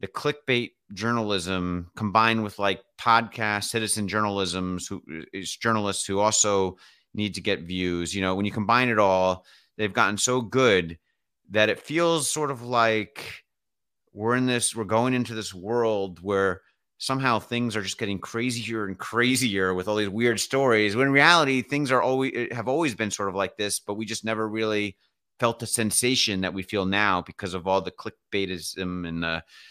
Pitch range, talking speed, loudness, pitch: 95-120 Hz, 180 wpm, -25 LUFS, 105 Hz